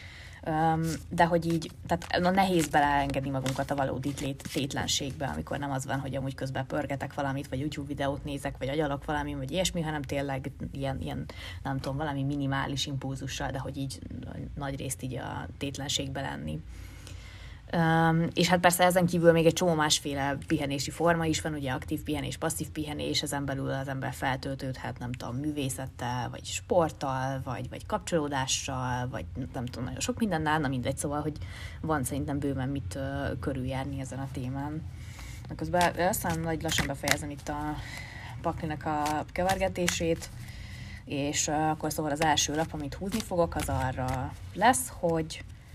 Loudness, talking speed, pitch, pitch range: -30 LUFS, 160 wpm, 140 Hz, 130-155 Hz